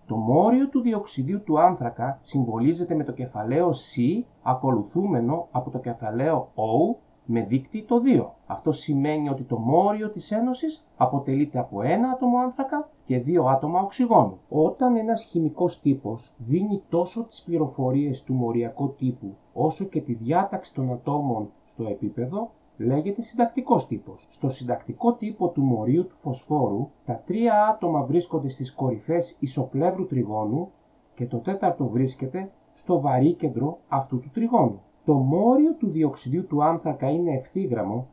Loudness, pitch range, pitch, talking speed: -25 LUFS, 130-190 Hz, 150 Hz, 145 wpm